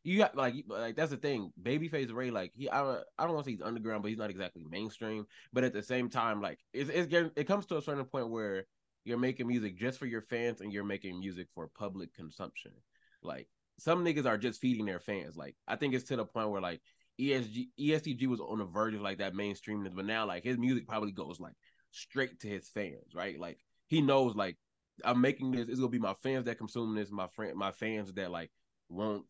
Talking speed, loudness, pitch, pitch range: 235 wpm, -36 LUFS, 115 Hz, 100-130 Hz